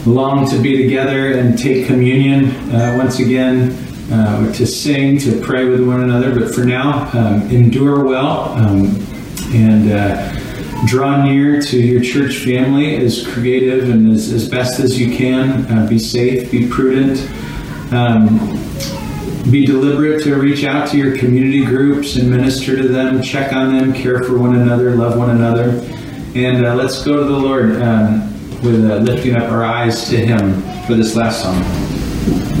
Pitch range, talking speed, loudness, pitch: 115-135 Hz, 165 wpm, -13 LUFS, 125 Hz